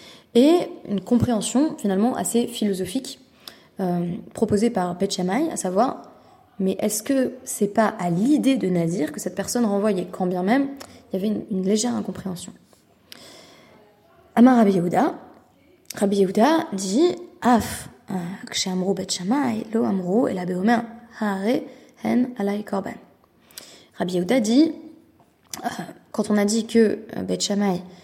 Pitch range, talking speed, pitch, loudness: 190-245 Hz, 110 wpm, 215 Hz, -22 LUFS